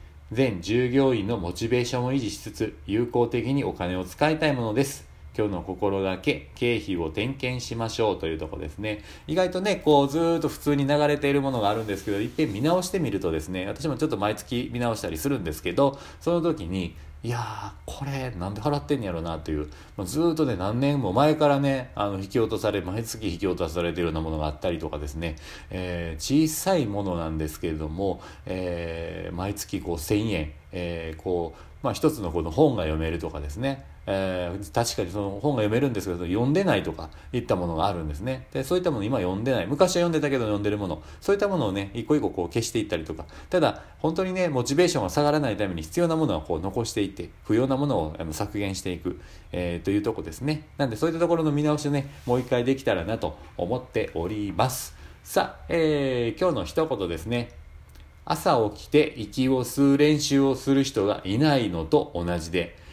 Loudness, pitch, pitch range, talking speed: -26 LUFS, 105 Hz, 85-140 Hz, 420 characters per minute